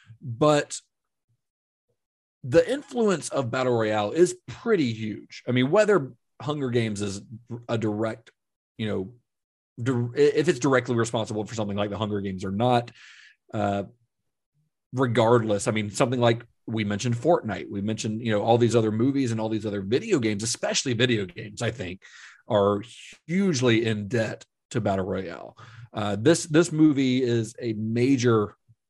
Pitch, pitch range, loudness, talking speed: 115 Hz, 105-130 Hz, -25 LUFS, 155 wpm